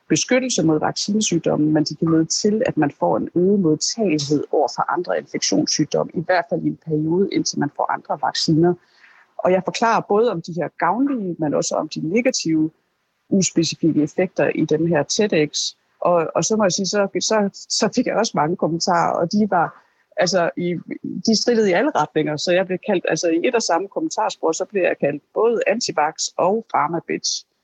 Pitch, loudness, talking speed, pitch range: 180 Hz, -20 LUFS, 195 wpm, 160-215 Hz